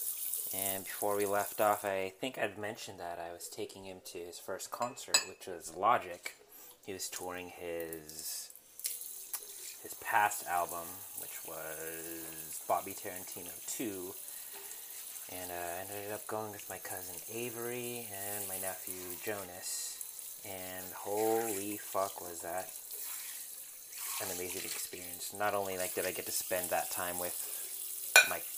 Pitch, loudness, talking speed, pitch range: 95 Hz, -36 LUFS, 140 wpm, 90-105 Hz